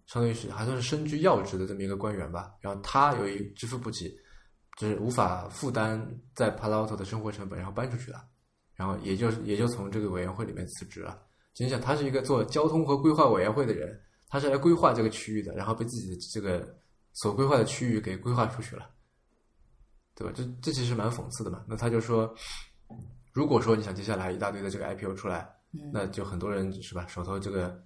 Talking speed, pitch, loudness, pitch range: 340 characters per minute, 110 Hz, -30 LUFS, 100-125 Hz